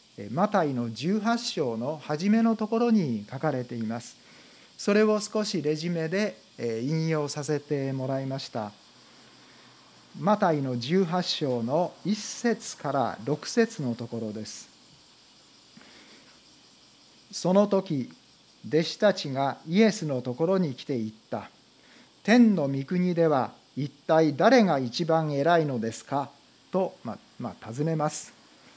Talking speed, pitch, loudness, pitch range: 225 characters per minute, 155 Hz, -27 LUFS, 135-195 Hz